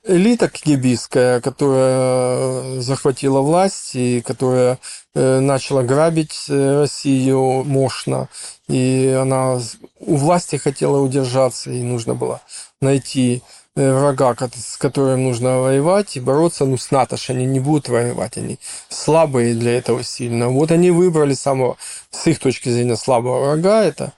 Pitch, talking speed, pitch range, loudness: 130 Hz, 130 wpm, 125-145 Hz, -17 LUFS